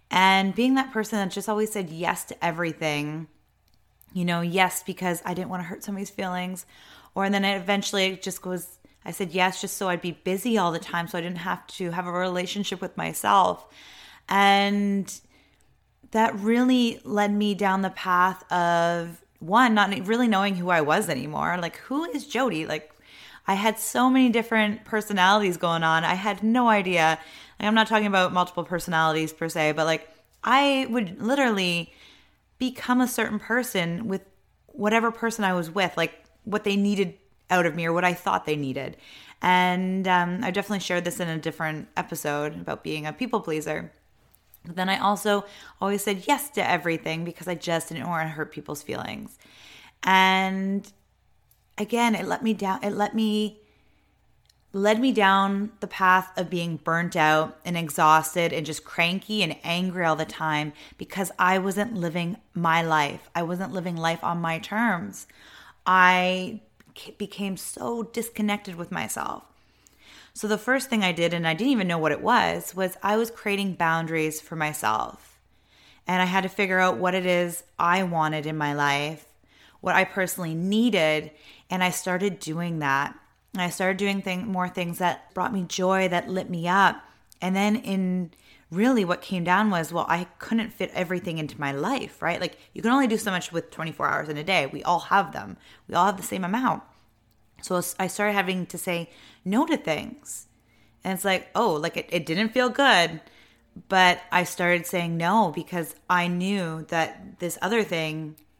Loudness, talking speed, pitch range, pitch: -25 LUFS, 185 wpm, 170-205 Hz, 185 Hz